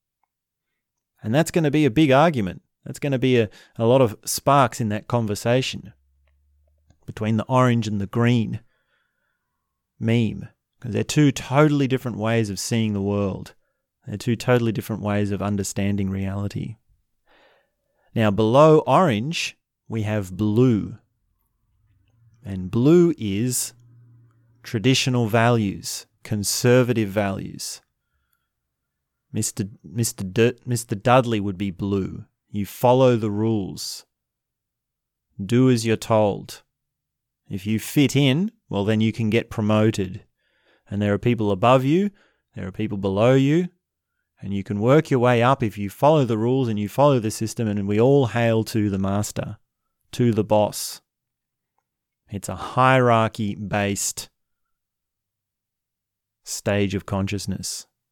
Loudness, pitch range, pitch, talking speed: -21 LUFS, 100-125 Hz, 110 Hz, 135 wpm